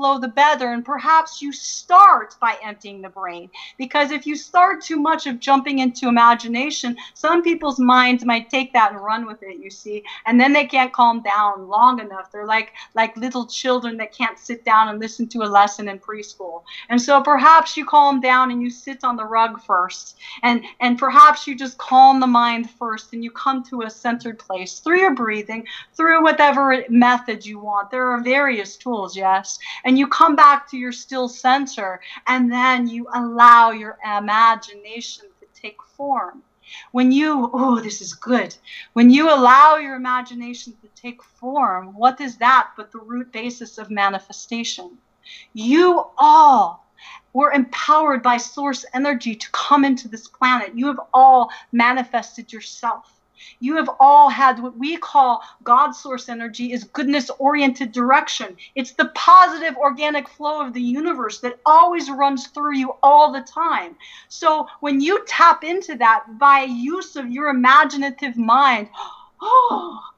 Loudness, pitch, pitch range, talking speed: -16 LUFS, 255 Hz, 230-285 Hz, 170 wpm